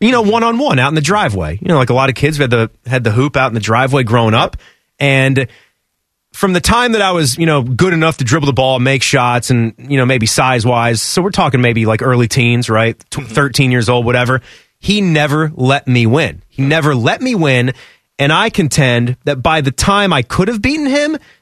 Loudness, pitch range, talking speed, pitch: -12 LUFS, 120-160 Hz, 240 wpm, 135 Hz